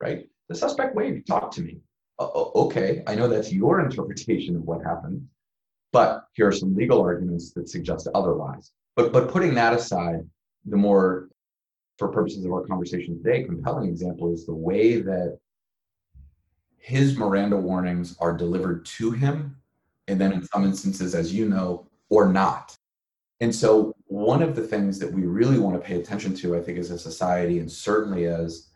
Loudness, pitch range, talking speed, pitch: -24 LUFS, 85-105 Hz, 175 wpm, 90 Hz